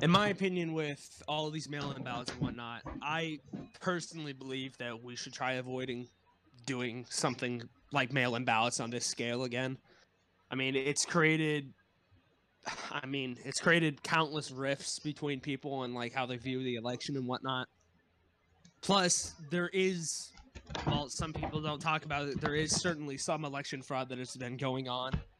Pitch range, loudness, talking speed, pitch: 125-155 Hz, -35 LUFS, 170 wpm, 135 Hz